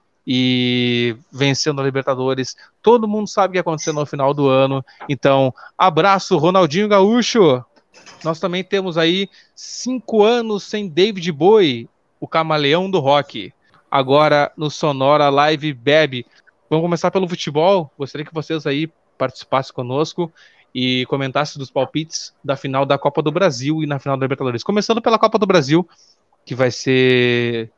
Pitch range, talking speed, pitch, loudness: 135-185 Hz, 150 wpm, 150 Hz, -17 LUFS